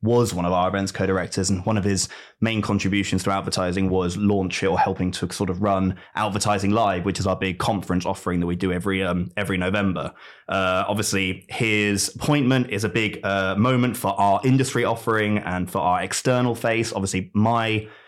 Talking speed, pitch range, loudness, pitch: 190 wpm, 95-110 Hz, -22 LUFS, 100 Hz